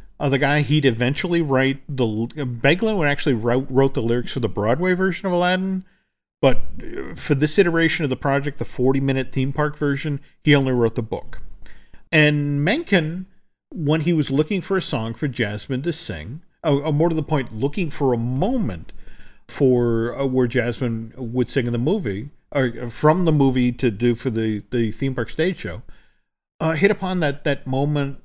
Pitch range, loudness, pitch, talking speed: 125-155 Hz, -21 LUFS, 140 Hz, 190 wpm